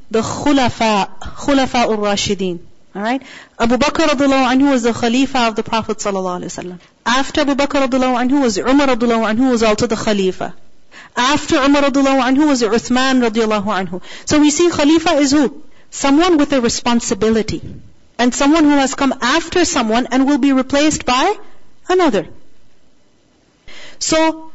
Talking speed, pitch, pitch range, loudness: 160 wpm, 255 Hz, 225-285 Hz, -15 LUFS